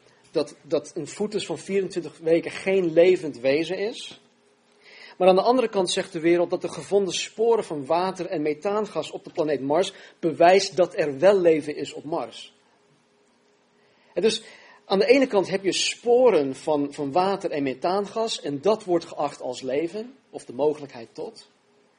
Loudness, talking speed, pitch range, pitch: -23 LUFS, 170 wpm, 155-205 Hz, 180 Hz